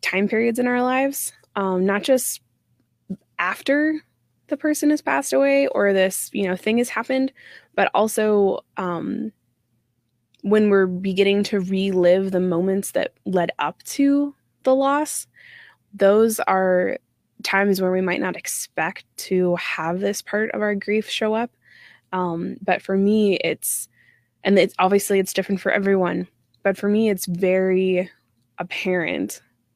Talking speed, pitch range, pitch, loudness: 145 wpm, 180-225 Hz, 195 Hz, -21 LUFS